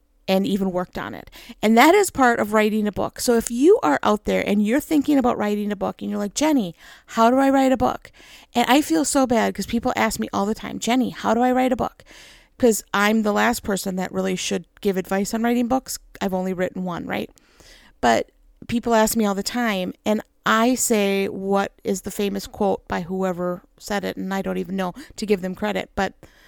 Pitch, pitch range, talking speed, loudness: 215 Hz, 195-245 Hz, 230 wpm, -21 LUFS